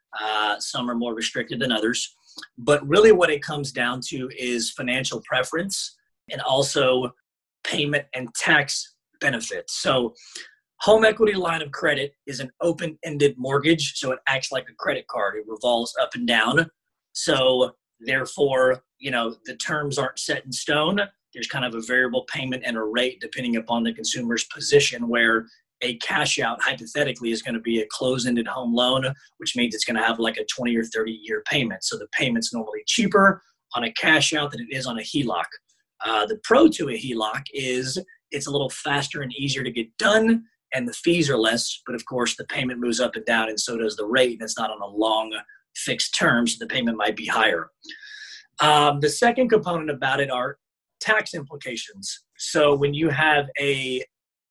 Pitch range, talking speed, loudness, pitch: 120-150 Hz, 190 wpm, -23 LUFS, 130 Hz